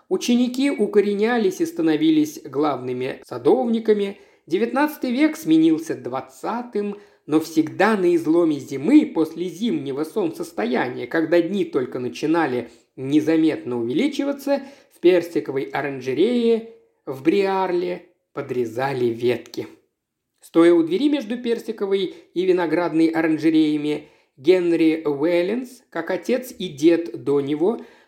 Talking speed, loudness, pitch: 100 wpm, -21 LUFS, 190 Hz